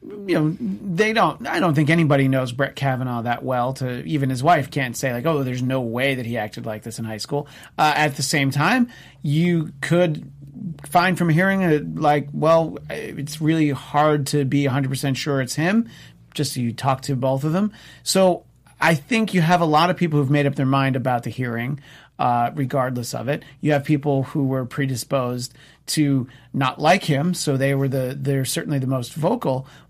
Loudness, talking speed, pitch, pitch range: -21 LUFS, 205 wpm, 140 Hz, 130-160 Hz